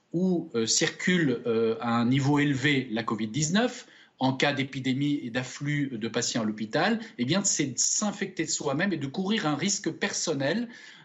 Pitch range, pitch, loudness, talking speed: 125-190 Hz, 145 Hz, -27 LUFS, 170 wpm